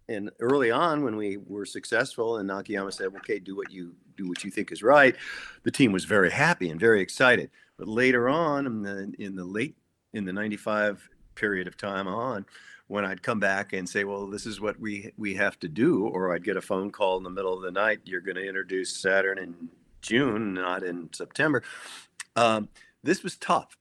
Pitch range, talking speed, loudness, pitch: 95-105 Hz, 210 wpm, -27 LUFS, 100 Hz